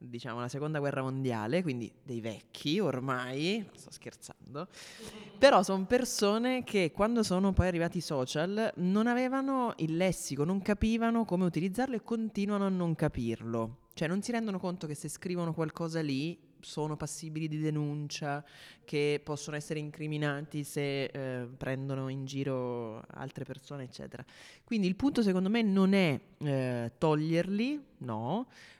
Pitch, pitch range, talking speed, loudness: 160 Hz, 140-200 Hz, 145 wpm, -32 LUFS